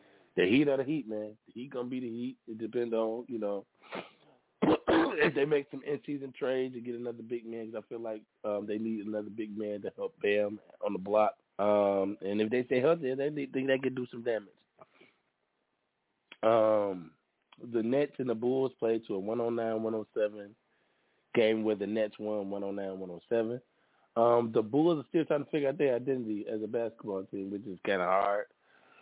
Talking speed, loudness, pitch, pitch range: 195 wpm, -32 LUFS, 115 Hz, 105-130 Hz